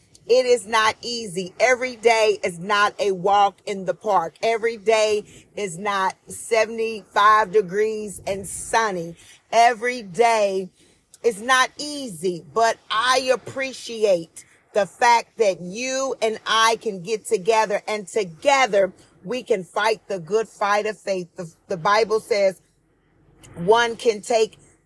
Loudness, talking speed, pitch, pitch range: -21 LUFS, 135 wpm, 215 Hz, 195-230 Hz